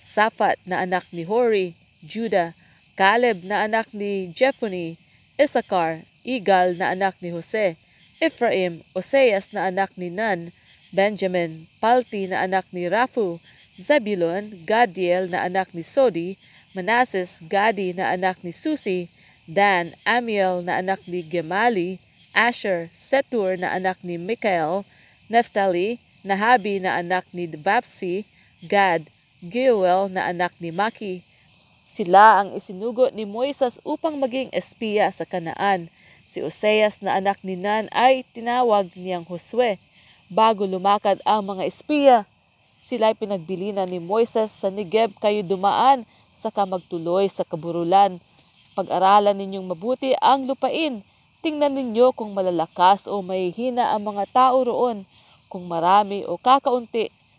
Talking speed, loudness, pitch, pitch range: 125 wpm, -22 LUFS, 195 Hz, 180-230 Hz